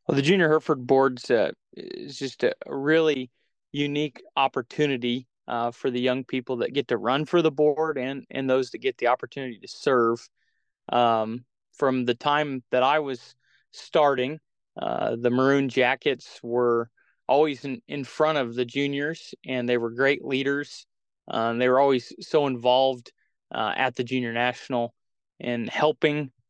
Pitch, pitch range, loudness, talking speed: 130 Hz, 120-145 Hz, -25 LUFS, 160 wpm